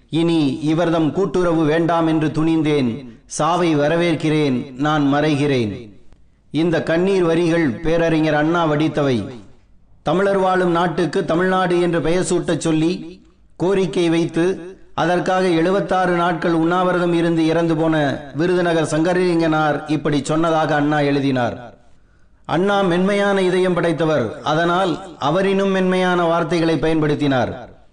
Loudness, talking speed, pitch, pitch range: -18 LUFS, 105 wpm, 165 Hz, 150-175 Hz